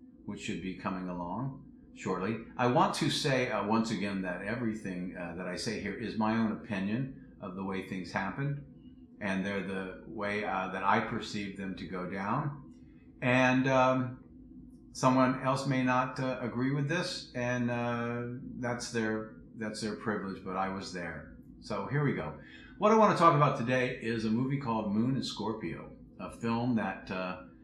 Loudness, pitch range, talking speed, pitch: -32 LUFS, 95-130 Hz, 180 wpm, 115 Hz